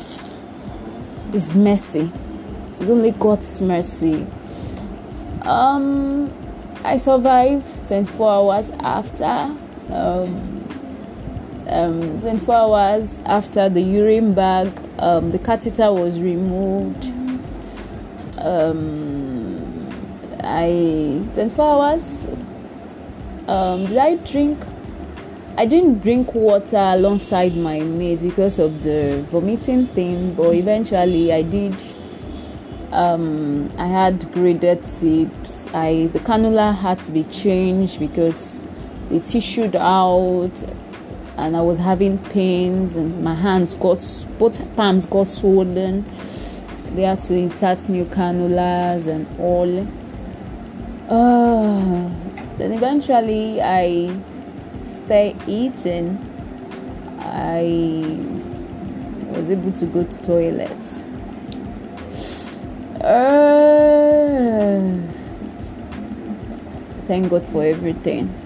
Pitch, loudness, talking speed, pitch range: 185 Hz, -18 LUFS, 95 wpm, 175-220 Hz